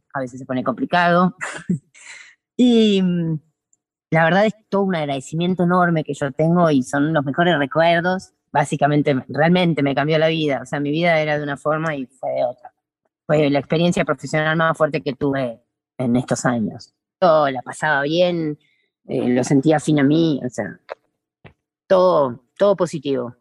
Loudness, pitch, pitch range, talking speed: -19 LUFS, 155 Hz, 140-170 Hz, 165 wpm